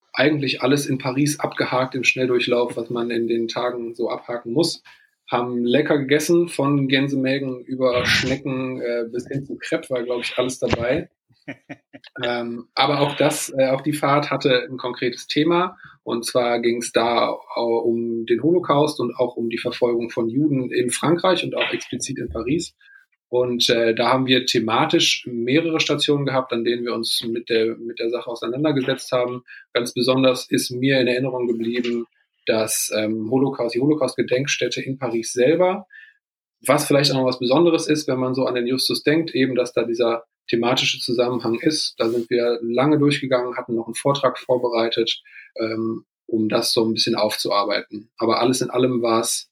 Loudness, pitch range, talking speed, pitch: -21 LUFS, 120-140 Hz, 175 wpm, 125 Hz